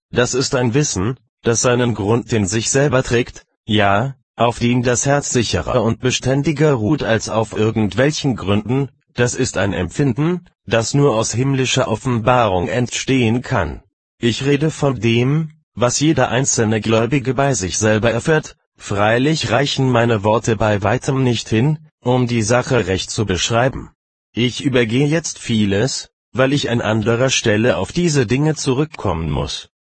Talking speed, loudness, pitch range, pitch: 150 wpm, -17 LUFS, 110-135 Hz, 120 Hz